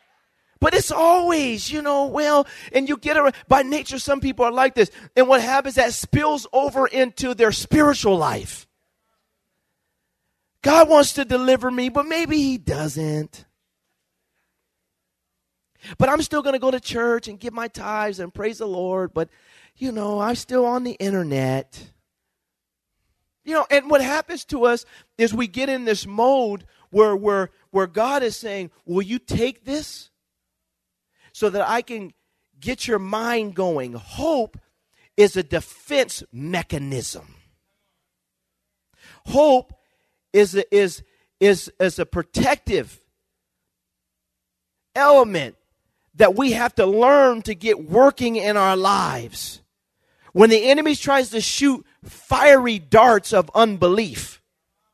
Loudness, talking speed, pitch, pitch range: -19 LUFS, 135 wpm, 235 Hz, 195-270 Hz